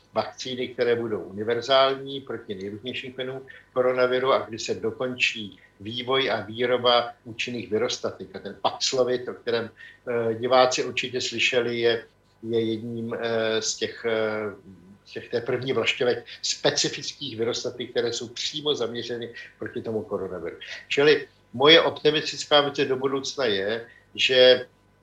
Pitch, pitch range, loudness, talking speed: 120 Hz, 115-130 Hz, -24 LUFS, 120 wpm